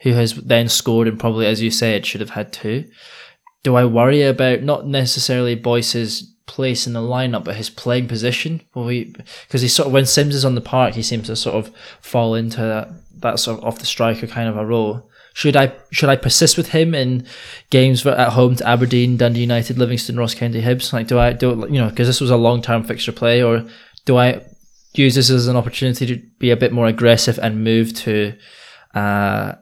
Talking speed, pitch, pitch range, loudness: 225 wpm, 120 Hz, 115-130 Hz, -17 LUFS